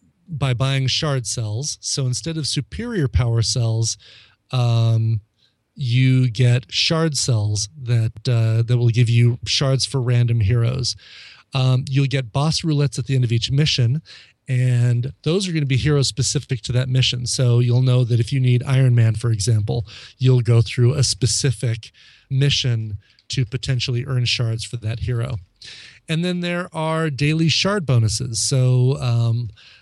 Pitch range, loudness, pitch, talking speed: 115-135 Hz, -19 LUFS, 125 Hz, 160 wpm